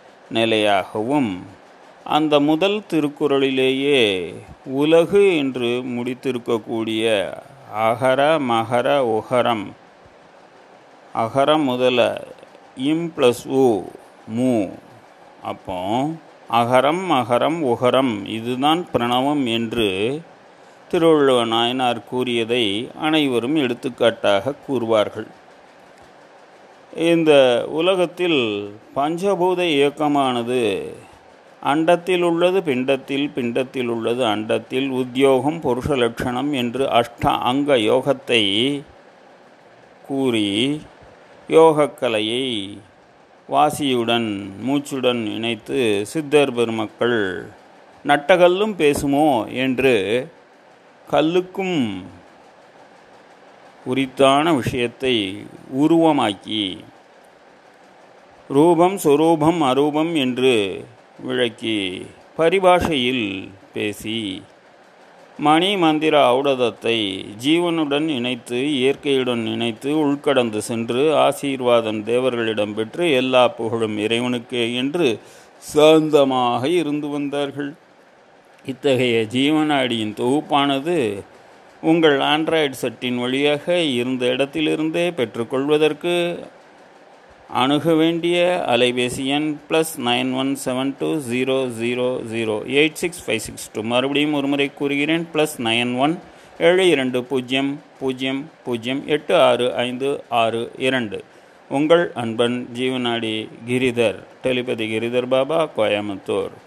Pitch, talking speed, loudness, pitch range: 130 Hz, 75 wpm, -19 LUFS, 120-150 Hz